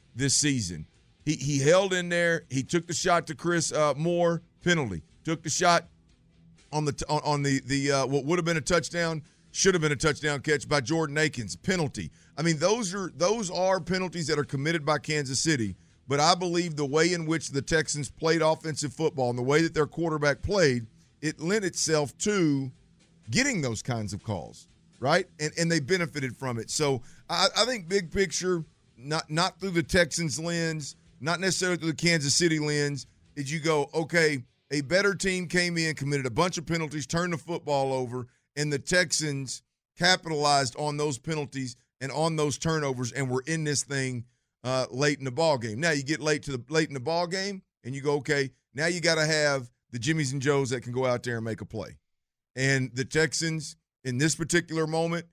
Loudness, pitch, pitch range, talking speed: -27 LUFS, 155 Hz, 135-170 Hz, 205 wpm